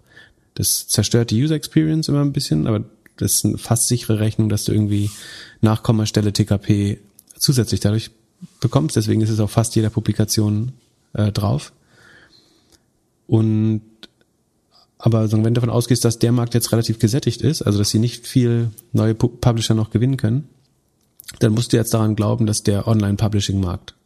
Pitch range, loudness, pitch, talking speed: 105-120 Hz, -19 LUFS, 110 Hz, 165 wpm